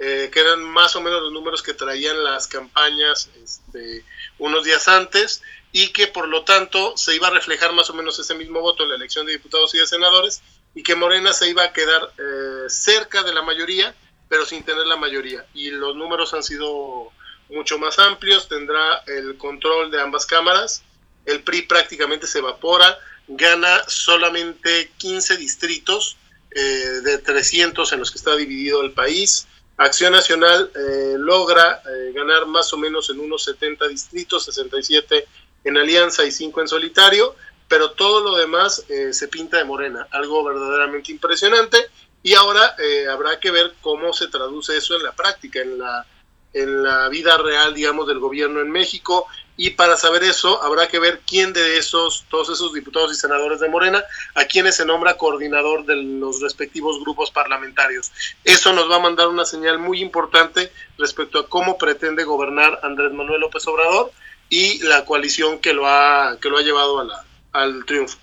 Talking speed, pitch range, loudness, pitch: 180 wpm, 150-190 Hz, -16 LUFS, 165 Hz